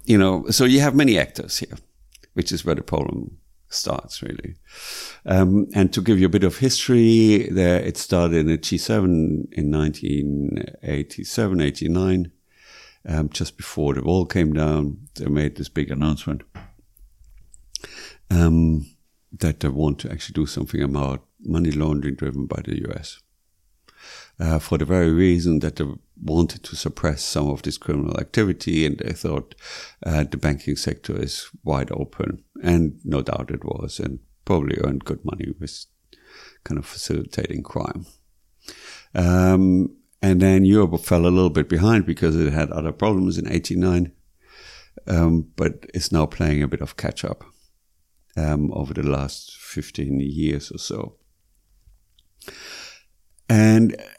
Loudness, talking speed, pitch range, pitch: -21 LUFS, 150 wpm, 75-90 Hz, 80 Hz